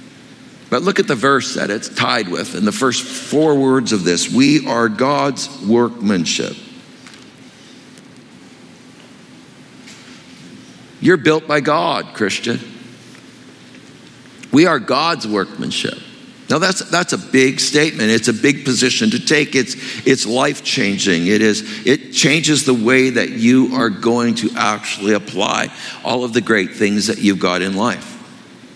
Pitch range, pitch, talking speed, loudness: 110-150 Hz, 130 Hz, 140 wpm, -16 LUFS